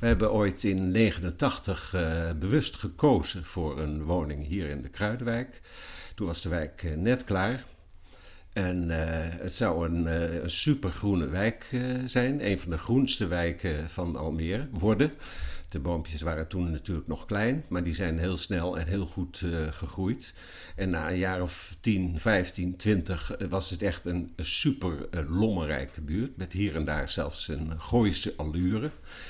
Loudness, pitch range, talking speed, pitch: -30 LUFS, 80-100 Hz, 175 wpm, 90 Hz